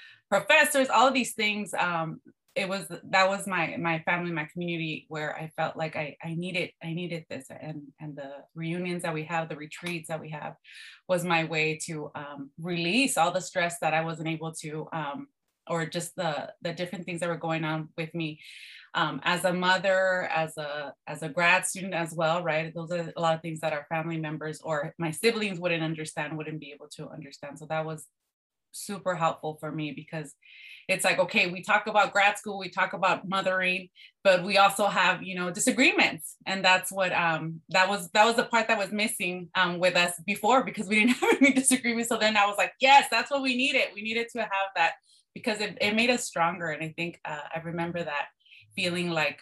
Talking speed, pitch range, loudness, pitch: 215 wpm, 160-200 Hz, -27 LUFS, 175 Hz